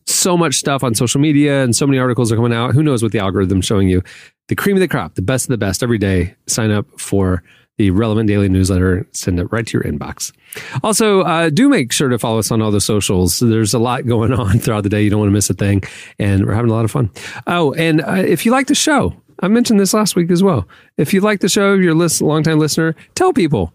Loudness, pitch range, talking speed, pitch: -15 LUFS, 105-165 Hz, 265 wpm, 120 Hz